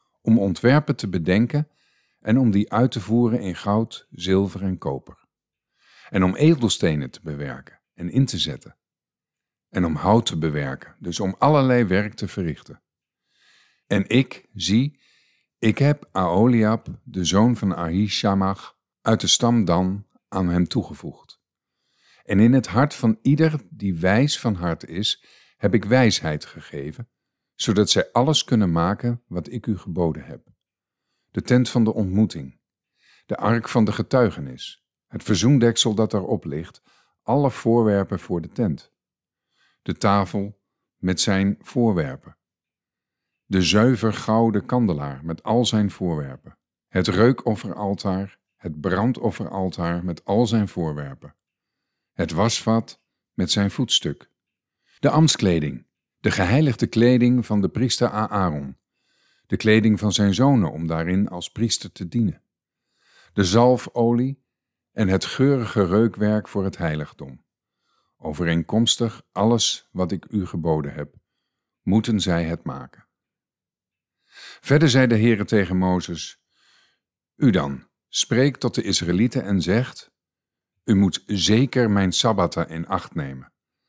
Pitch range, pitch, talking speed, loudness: 95-120 Hz, 105 Hz, 130 wpm, -21 LUFS